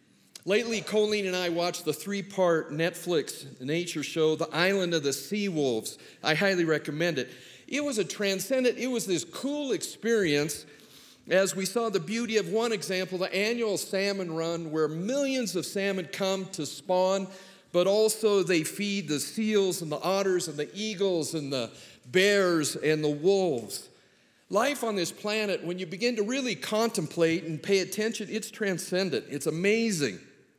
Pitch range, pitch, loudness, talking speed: 165-210 Hz, 190 Hz, -28 LUFS, 165 wpm